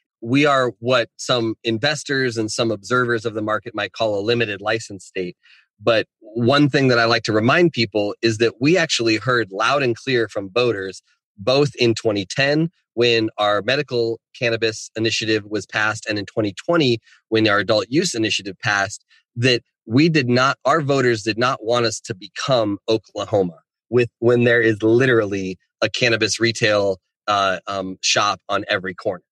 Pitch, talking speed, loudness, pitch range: 115 Hz, 170 wpm, -19 LUFS, 105-125 Hz